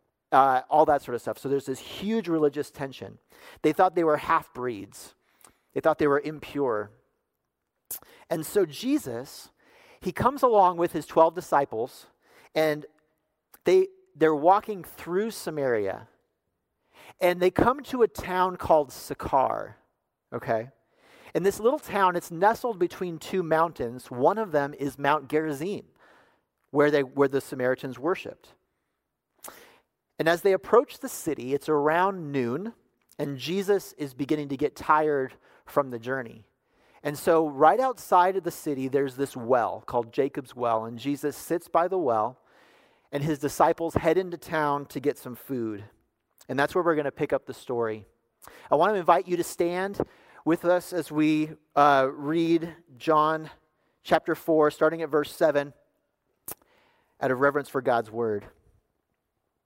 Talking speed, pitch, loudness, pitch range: 155 wpm, 155 Hz, -26 LUFS, 135-175 Hz